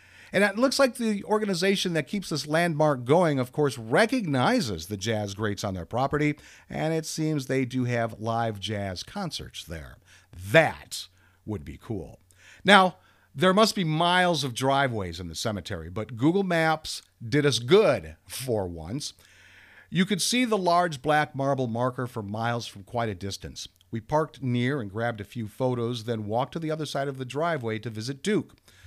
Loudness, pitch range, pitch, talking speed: -26 LUFS, 105-160 Hz, 130 Hz, 180 wpm